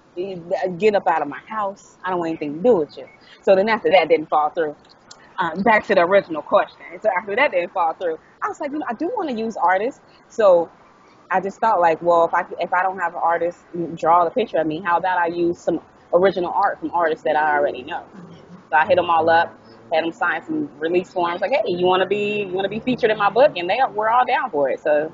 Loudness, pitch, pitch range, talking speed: -20 LUFS, 185 Hz, 170-220 Hz, 265 wpm